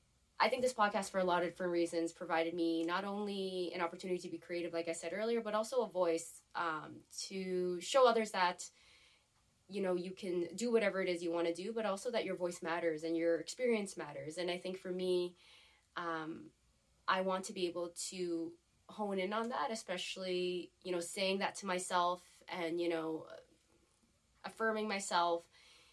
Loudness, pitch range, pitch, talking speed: -38 LUFS, 170-195 Hz, 180 Hz, 190 wpm